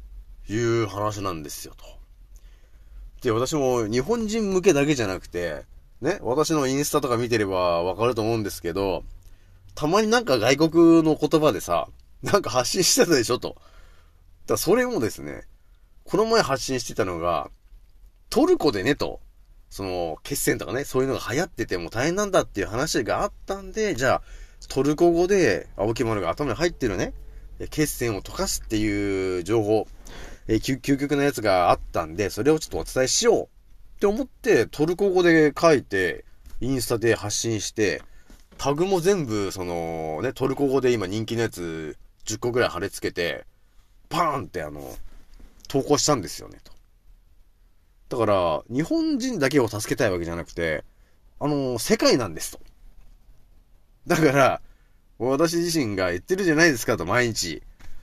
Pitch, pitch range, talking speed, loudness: 120 Hz, 95-155 Hz, 315 characters per minute, -23 LUFS